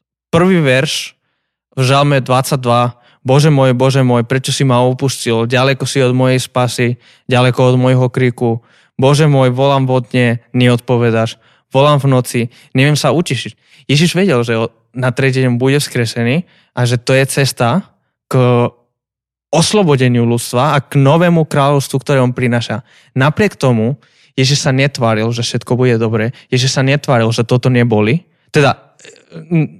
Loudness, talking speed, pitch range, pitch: -13 LUFS, 145 wpm, 120-140 Hz, 130 Hz